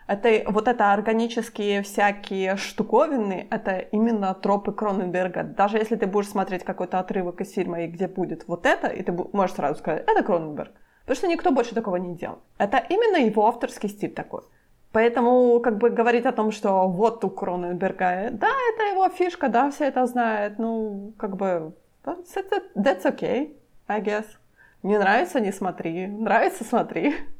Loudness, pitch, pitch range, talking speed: -24 LUFS, 215 Hz, 195-245 Hz, 165 wpm